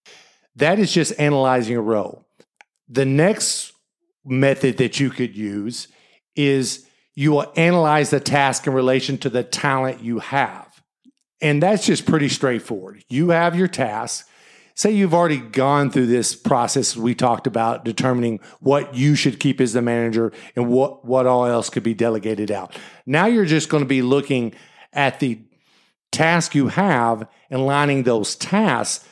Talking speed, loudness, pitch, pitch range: 160 wpm, -19 LUFS, 135 Hz, 120-150 Hz